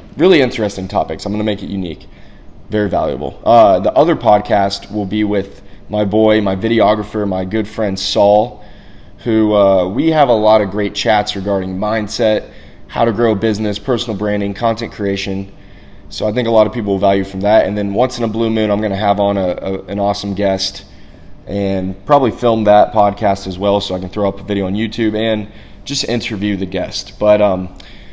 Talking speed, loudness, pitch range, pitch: 205 wpm, -15 LUFS, 95-110 Hz, 105 Hz